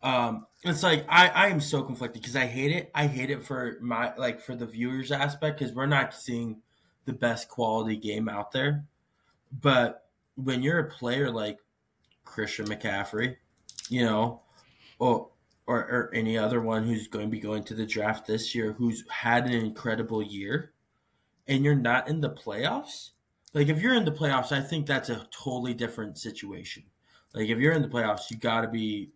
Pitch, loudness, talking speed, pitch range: 120 Hz, -28 LUFS, 200 wpm, 110-140 Hz